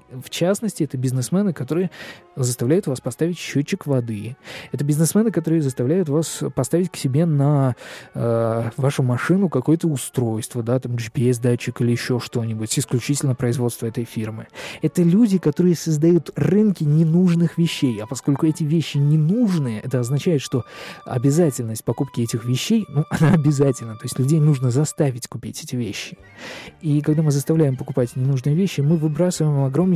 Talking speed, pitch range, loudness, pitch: 150 wpm, 125-165 Hz, -20 LUFS, 145 Hz